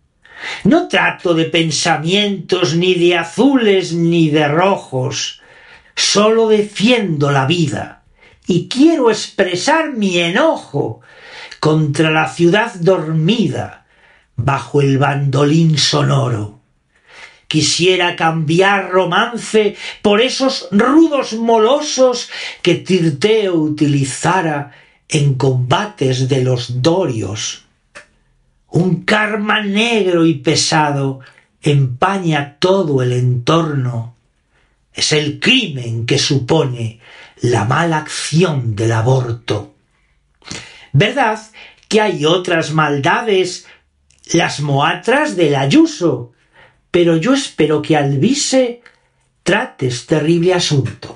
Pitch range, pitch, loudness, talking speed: 140-205 Hz, 165 Hz, -14 LUFS, 95 wpm